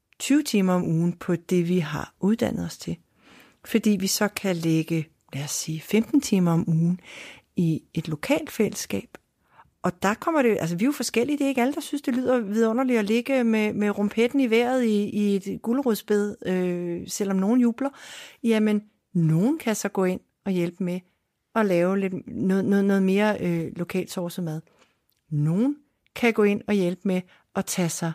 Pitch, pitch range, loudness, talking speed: 200 Hz, 175-230 Hz, -24 LUFS, 190 wpm